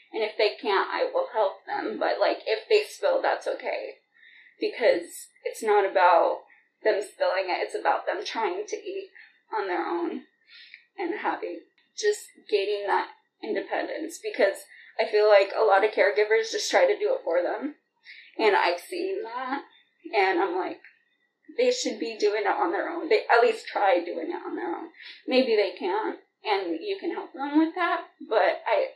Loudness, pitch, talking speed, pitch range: -26 LUFS, 395 Hz, 180 wpm, 340-440 Hz